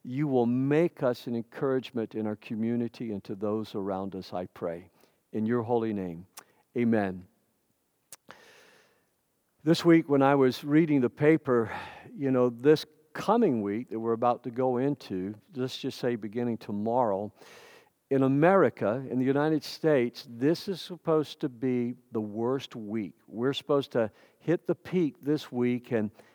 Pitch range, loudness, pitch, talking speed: 110-145 Hz, -29 LUFS, 125 Hz, 155 wpm